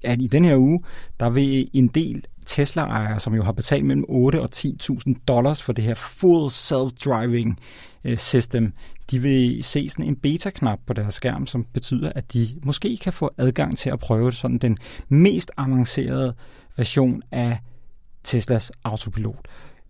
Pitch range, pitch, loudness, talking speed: 120-140 Hz, 125 Hz, -22 LUFS, 160 wpm